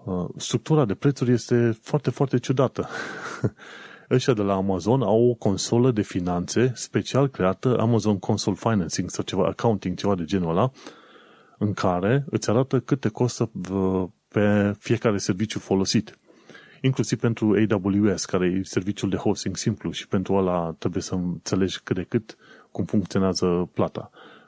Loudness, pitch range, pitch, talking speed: -24 LUFS, 95-120 Hz, 105 Hz, 145 wpm